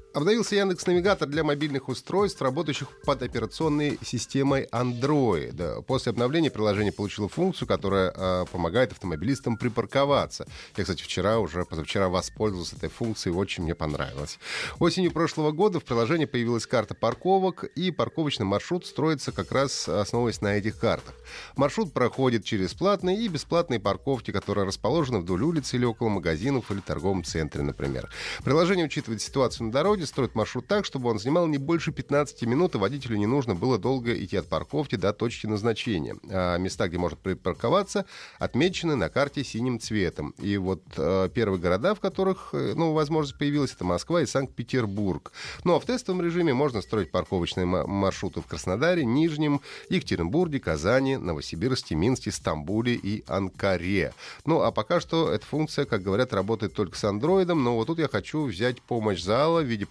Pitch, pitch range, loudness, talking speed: 120 Hz, 100-150 Hz, -27 LUFS, 160 wpm